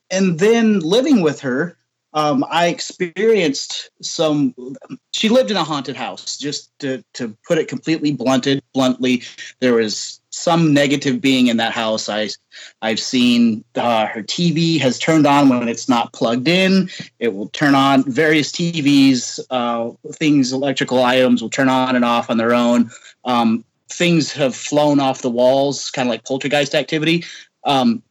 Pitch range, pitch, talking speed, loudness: 125-165 Hz, 140 Hz, 160 wpm, -17 LUFS